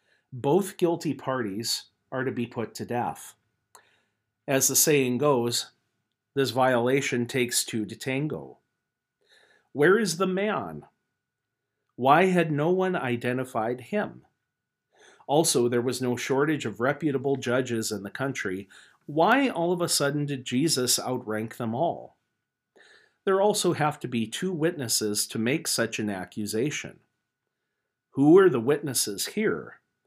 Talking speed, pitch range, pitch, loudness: 135 wpm, 120-165 Hz, 130 Hz, -26 LUFS